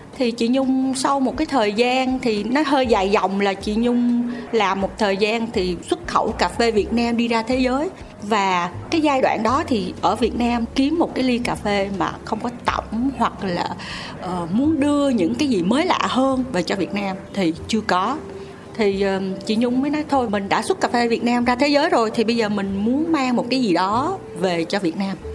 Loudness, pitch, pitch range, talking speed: -20 LUFS, 235 Hz, 200-260 Hz, 235 wpm